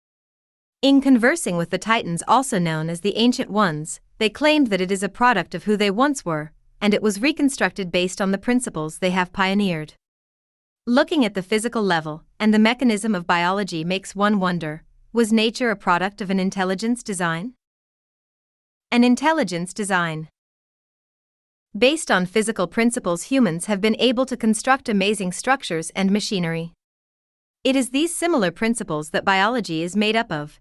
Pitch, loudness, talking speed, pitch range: 205 Hz, -21 LUFS, 165 wpm, 175-240 Hz